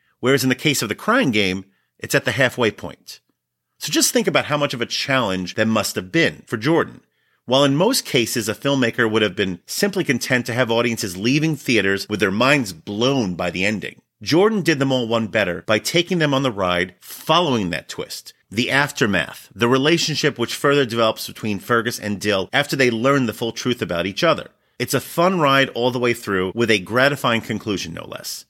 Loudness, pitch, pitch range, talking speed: -19 LUFS, 120 Hz, 105-140 Hz, 210 wpm